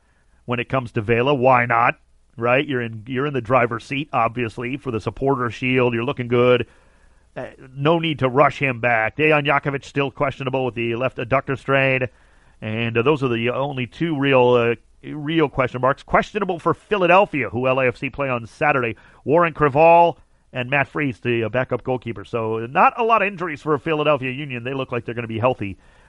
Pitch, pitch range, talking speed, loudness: 130 Hz, 120-145 Hz, 195 wpm, -20 LUFS